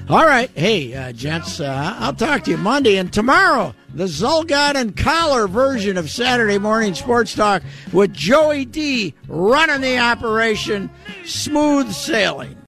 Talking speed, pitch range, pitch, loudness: 145 wpm, 185-275 Hz, 225 Hz, -17 LUFS